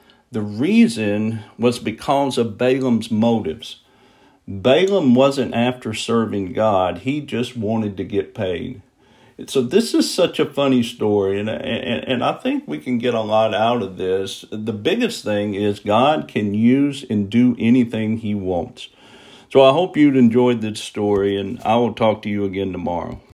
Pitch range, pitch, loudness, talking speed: 105-125 Hz, 110 Hz, -19 LUFS, 160 wpm